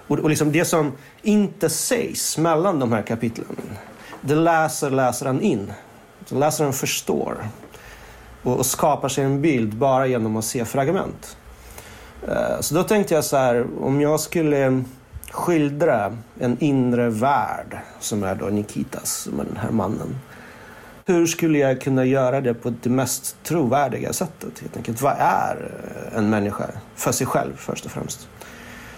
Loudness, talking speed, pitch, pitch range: -21 LUFS, 145 wpm, 135 Hz, 120-155 Hz